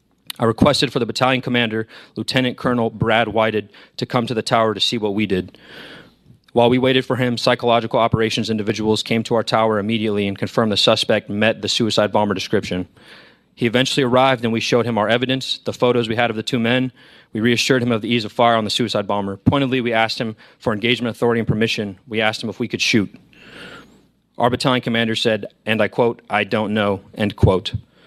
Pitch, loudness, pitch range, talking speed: 115 Hz, -18 LUFS, 110-125 Hz, 210 wpm